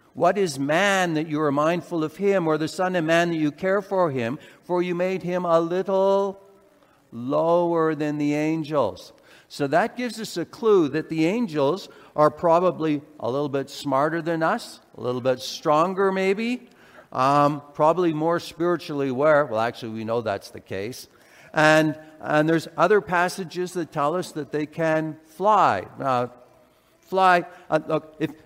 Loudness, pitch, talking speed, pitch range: -23 LUFS, 160 Hz, 170 wpm, 150-180 Hz